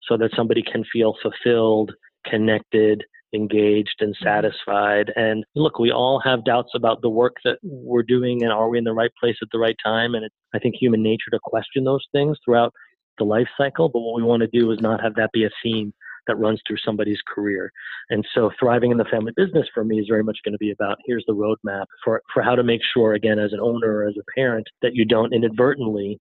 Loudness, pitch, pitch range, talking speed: -21 LUFS, 115 Hz, 110-120 Hz, 235 wpm